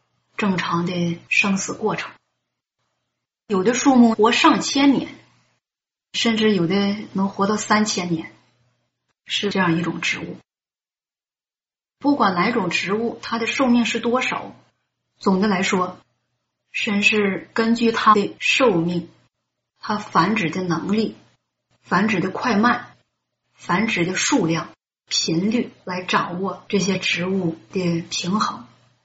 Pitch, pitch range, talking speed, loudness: 195 Hz, 170-220 Hz, 175 characters per minute, -20 LUFS